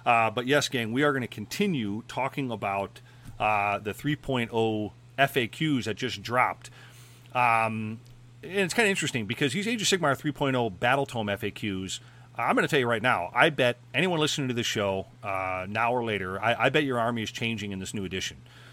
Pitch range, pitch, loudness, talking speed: 110-135 Hz, 120 Hz, -27 LUFS, 200 wpm